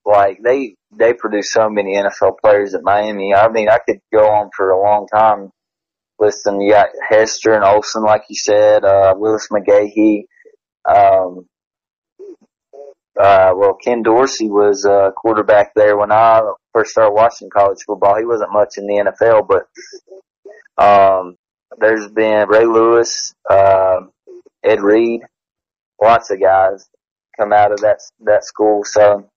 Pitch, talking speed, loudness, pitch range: 105 Hz, 150 wpm, -13 LUFS, 100-115 Hz